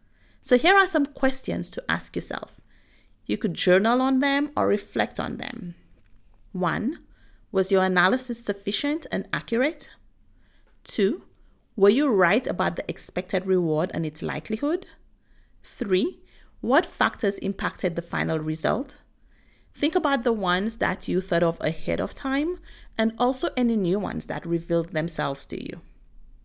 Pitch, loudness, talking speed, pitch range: 195 Hz, -24 LUFS, 145 wpm, 165-260 Hz